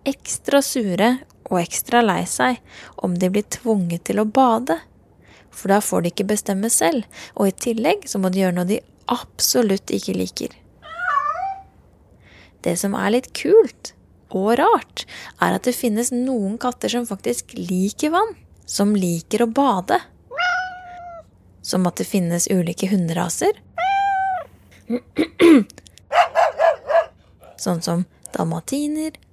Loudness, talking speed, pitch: -20 LUFS, 135 wpm, 225 Hz